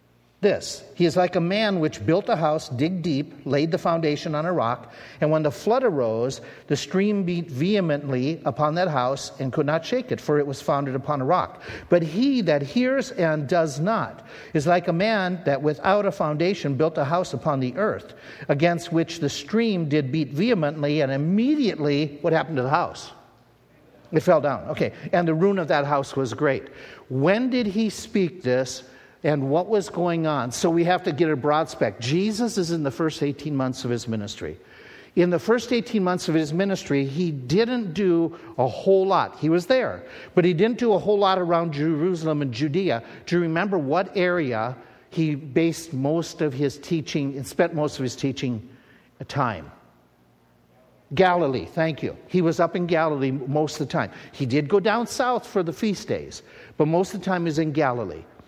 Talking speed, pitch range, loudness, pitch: 200 wpm, 145-185 Hz, -23 LUFS, 160 Hz